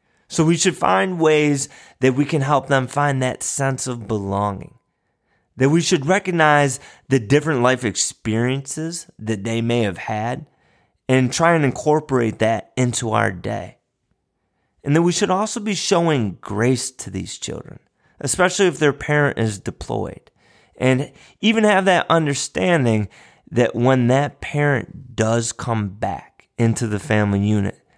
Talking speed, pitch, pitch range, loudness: 150 wpm, 130 Hz, 115-155 Hz, -19 LUFS